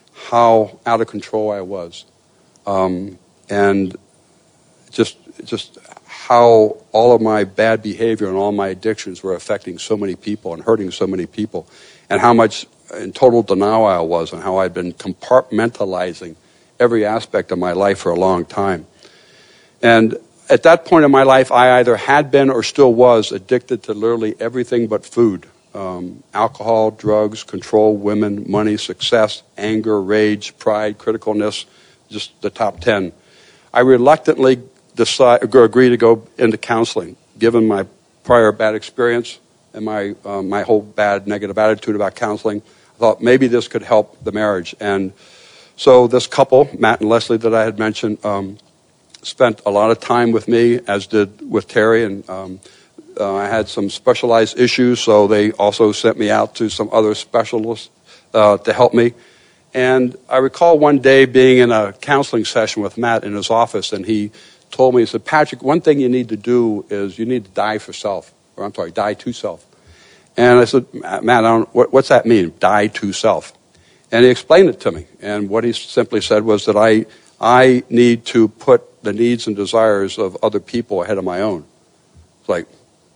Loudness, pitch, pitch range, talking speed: -15 LUFS, 110 Hz, 105-120 Hz, 180 wpm